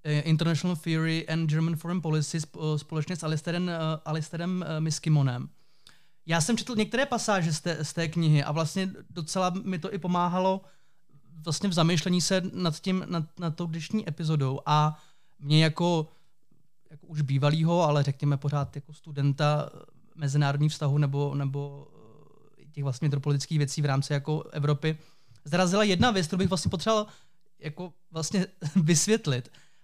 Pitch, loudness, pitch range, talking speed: 160 Hz, -28 LUFS, 150-180 Hz, 145 wpm